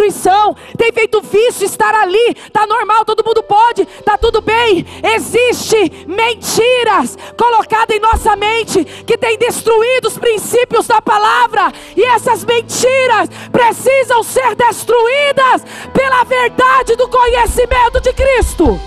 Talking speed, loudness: 120 wpm, -11 LUFS